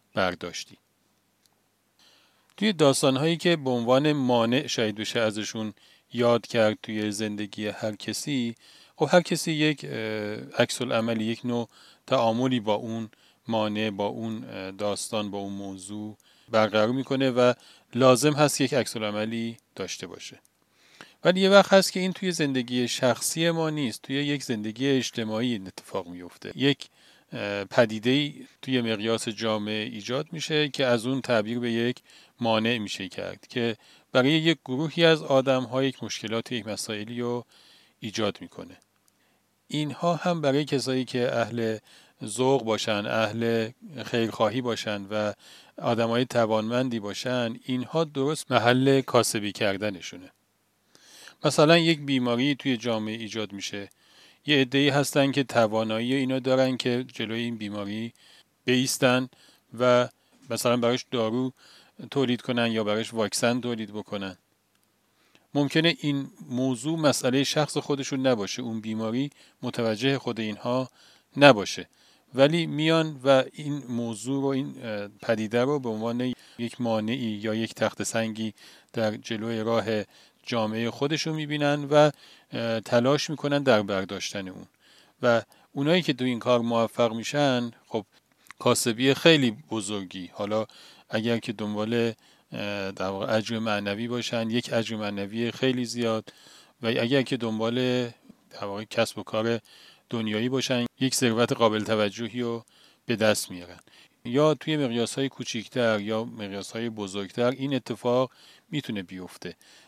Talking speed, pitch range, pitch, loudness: 135 wpm, 110-135 Hz, 120 Hz, -26 LUFS